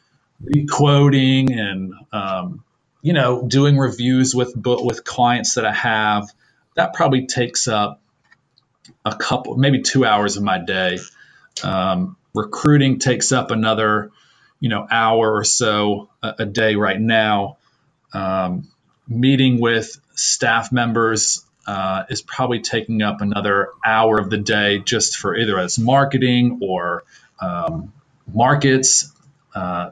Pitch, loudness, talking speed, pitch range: 120 Hz, -18 LUFS, 130 wpm, 105-130 Hz